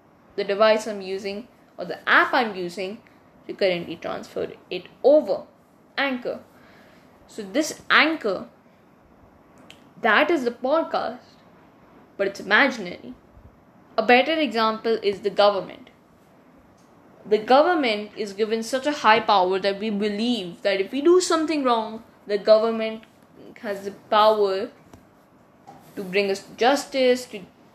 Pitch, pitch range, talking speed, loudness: 220 Hz, 200-265 Hz, 125 wpm, -22 LUFS